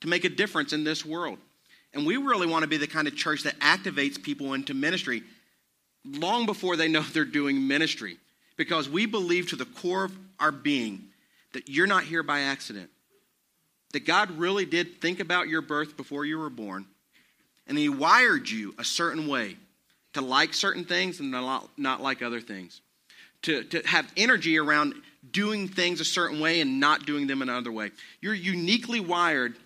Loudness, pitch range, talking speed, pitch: -26 LUFS, 140-190 Hz, 185 wpm, 160 Hz